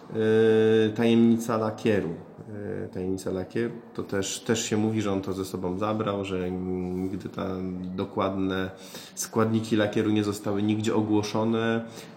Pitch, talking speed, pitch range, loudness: 105 Hz, 125 wpm, 95-110 Hz, -27 LUFS